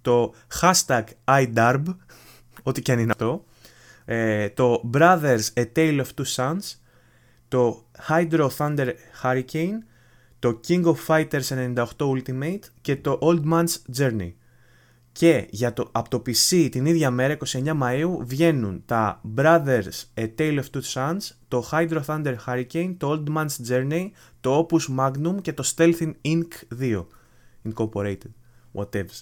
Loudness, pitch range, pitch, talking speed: -23 LUFS, 120-160 Hz, 130 Hz, 140 wpm